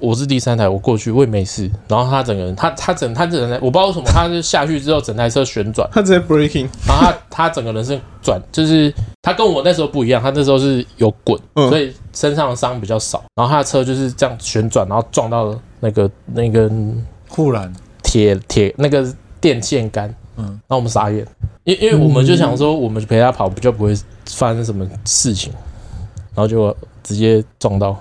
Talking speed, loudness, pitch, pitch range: 325 characters per minute, -15 LUFS, 115 Hz, 105-140 Hz